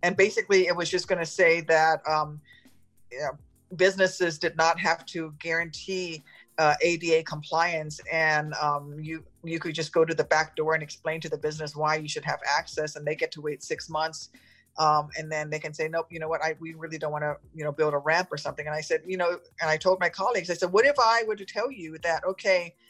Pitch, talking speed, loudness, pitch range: 160 Hz, 245 wpm, -26 LUFS, 155-175 Hz